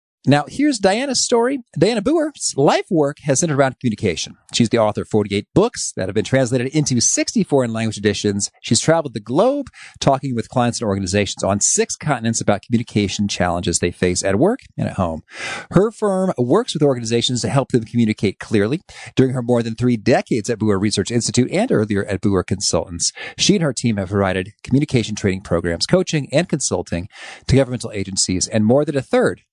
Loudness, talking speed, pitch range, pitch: -18 LUFS, 190 wpm, 105-145 Hz, 120 Hz